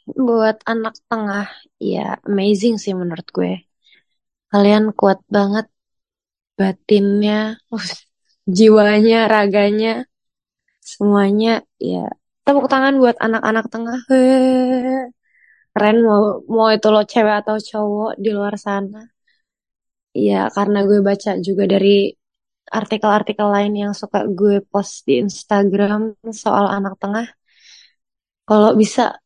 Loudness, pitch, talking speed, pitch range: -16 LUFS, 215 Hz, 105 wpm, 205-225 Hz